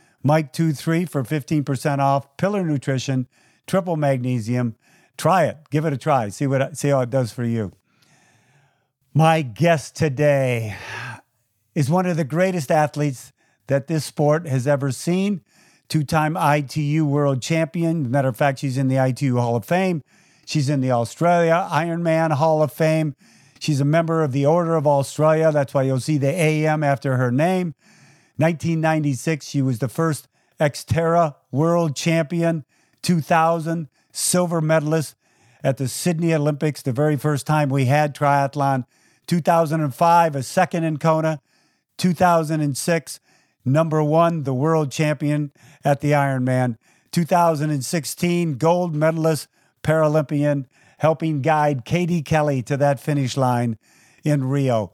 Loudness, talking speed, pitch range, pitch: -20 LUFS, 140 wpm, 135-165 Hz, 150 Hz